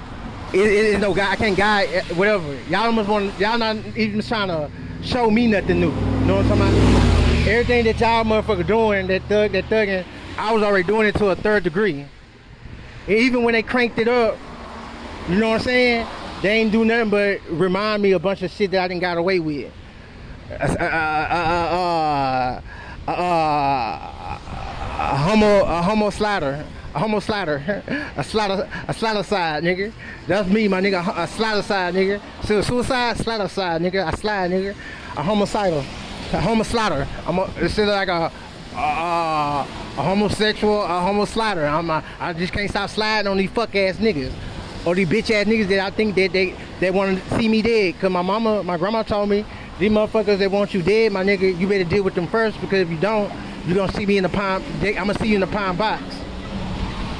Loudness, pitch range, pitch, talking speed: -20 LUFS, 175-215 Hz, 195 Hz, 200 wpm